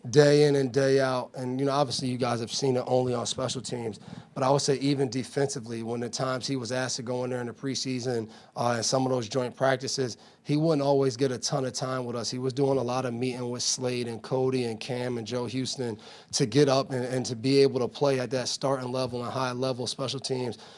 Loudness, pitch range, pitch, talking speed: -28 LUFS, 125-135 Hz, 130 Hz, 255 wpm